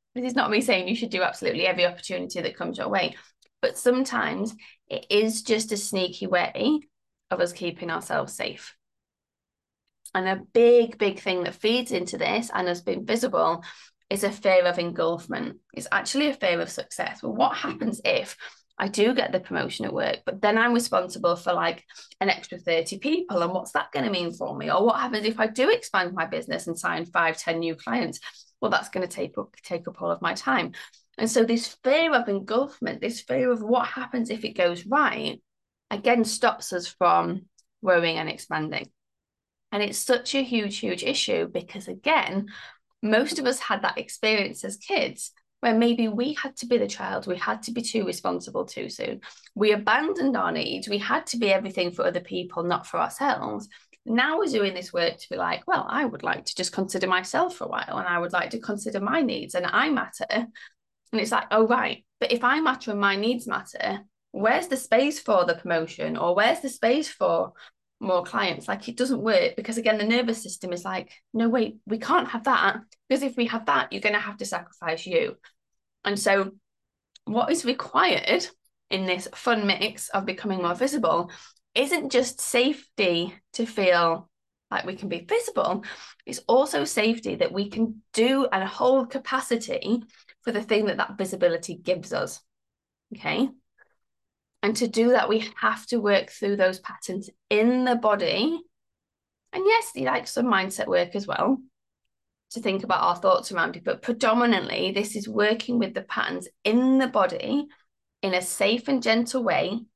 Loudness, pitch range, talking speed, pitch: -25 LUFS, 185-250 Hz, 190 wpm, 220 Hz